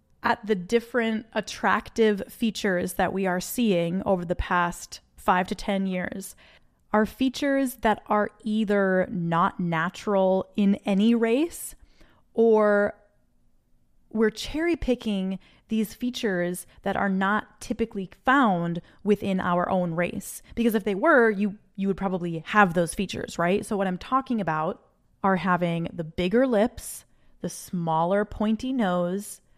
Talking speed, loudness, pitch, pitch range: 135 wpm, -25 LUFS, 200 Hz, 180-225 Hz